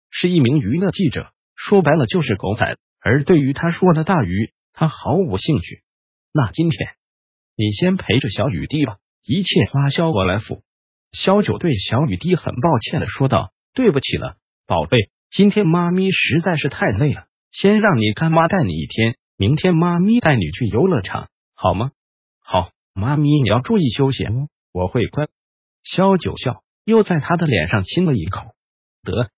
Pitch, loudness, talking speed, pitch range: 145 Hz, -18 LUFS, 245 characters per minute, 110-175 Hz